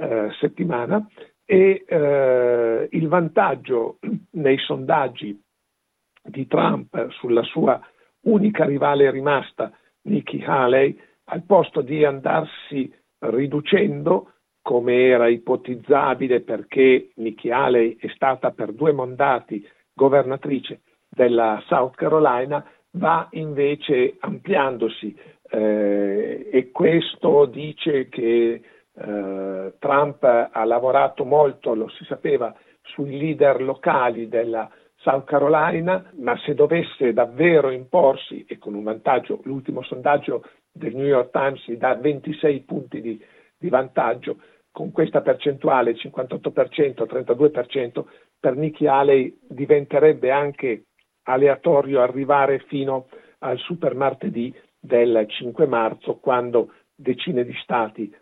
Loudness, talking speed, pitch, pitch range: -20 LUFS, 105 wpm, 135 Hz, 125-155 Hz